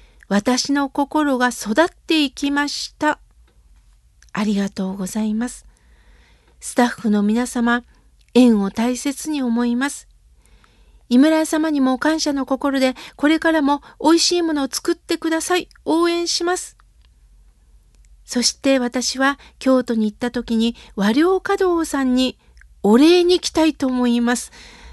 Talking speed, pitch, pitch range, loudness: 250 characters per minute, 270 Hz, 240-315 Hz, -19 LUFS